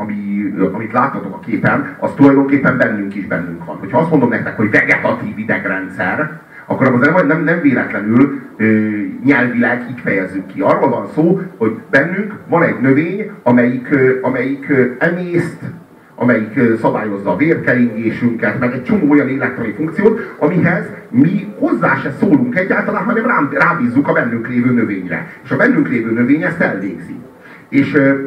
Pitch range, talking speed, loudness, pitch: 115-165 Hz, 145 wpm, -14 LUFS, 130 Hz